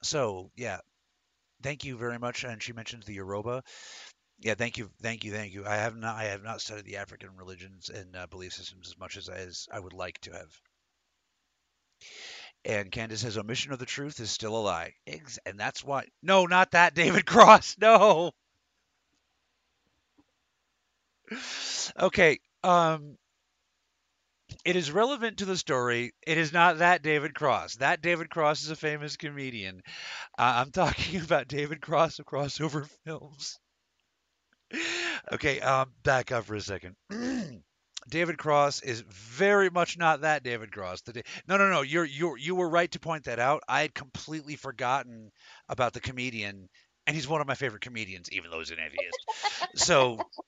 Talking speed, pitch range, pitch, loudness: 170 wpm, 110-165 Hz, 135 Hz, -27 LUFS